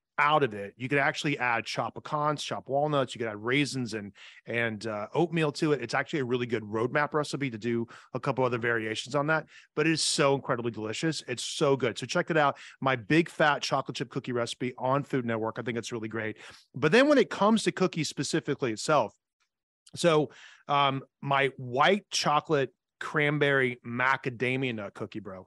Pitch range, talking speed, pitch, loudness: 120-150 Hz, 195 wpm, 135 Hz, -28 LUFS